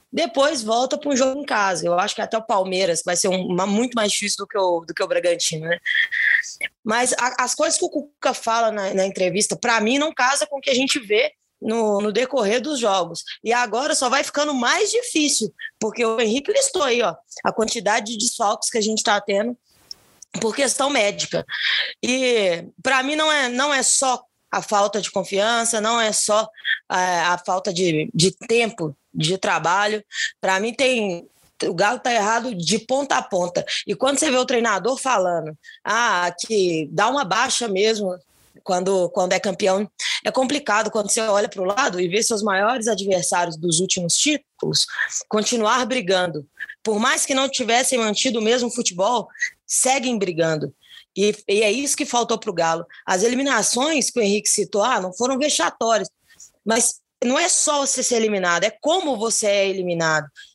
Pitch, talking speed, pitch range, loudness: 220 Hz, 185 wpm, 190-255 Hz, -20 LUFS